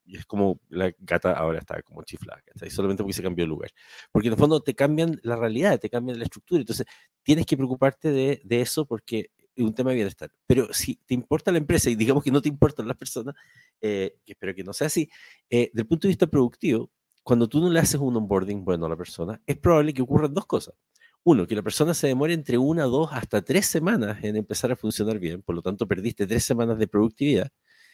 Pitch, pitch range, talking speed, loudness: 120 Hz, 105-150 Hz, 235 wpm, -25 LUFS